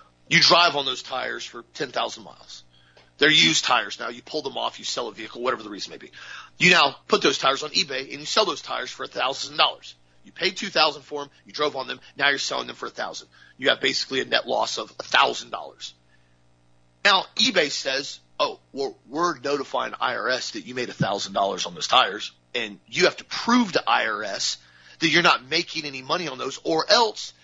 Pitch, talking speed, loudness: 130 Hz, 225 wpm, -22 LUFS